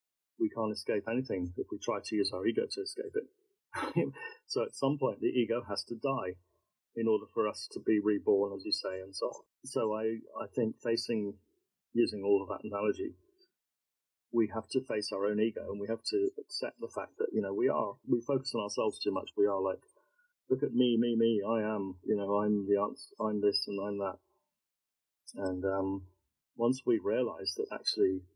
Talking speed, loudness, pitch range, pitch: 205 wpm, -33 LUFS, 100-130 Hz, 110 Hz